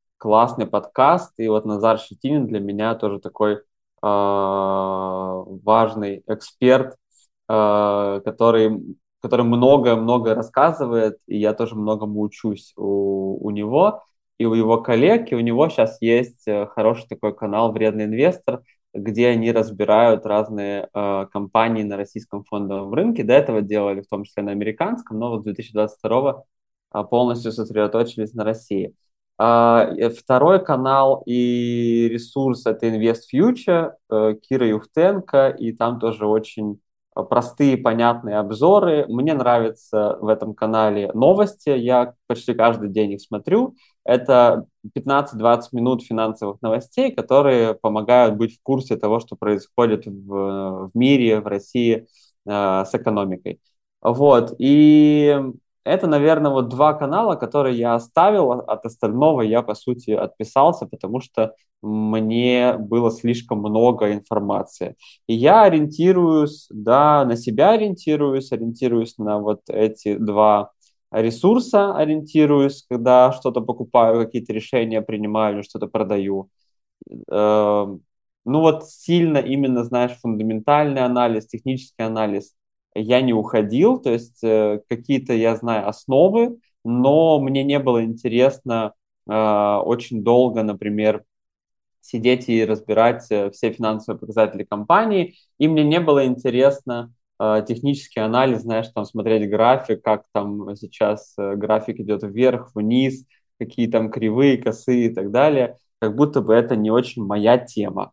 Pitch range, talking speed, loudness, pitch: 105-125 Hz, 130 wpm, -19 LUFS, 115 Hz